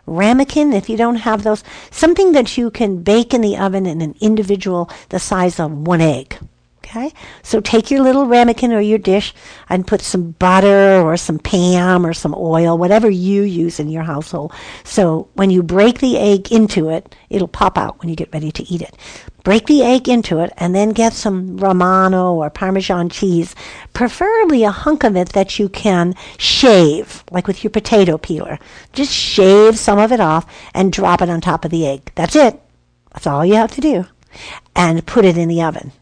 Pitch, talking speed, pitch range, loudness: 190 Hz, 200 wpm, 170-220 Hz, -14 LUFS